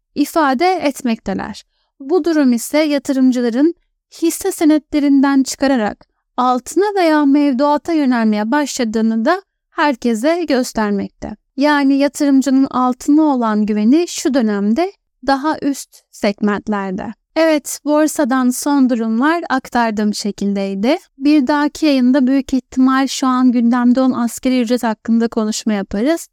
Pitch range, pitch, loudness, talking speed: 235-300 Hz, 270 Hz, -15 LUFS, 105 wpm